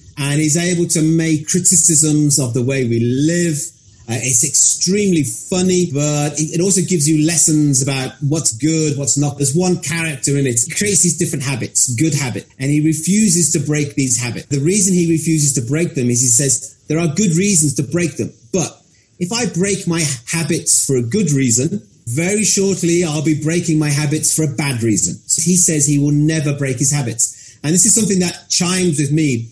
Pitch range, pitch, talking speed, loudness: 140-170 Hz, 155 Hz, 205 wpm, -15 LUFS